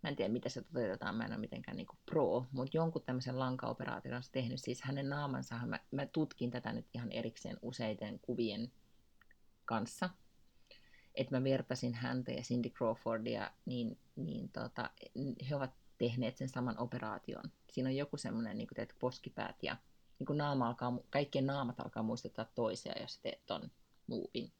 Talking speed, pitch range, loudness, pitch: 170 wpm, 120-135 Hz, -41 LUFS, 125 Hz